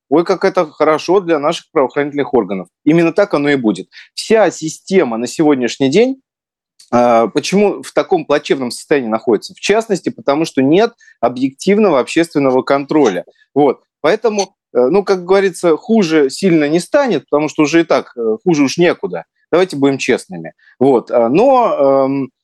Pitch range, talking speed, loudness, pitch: 140-195 Hz, 145 wpm, -14 LUFS, 160 Hz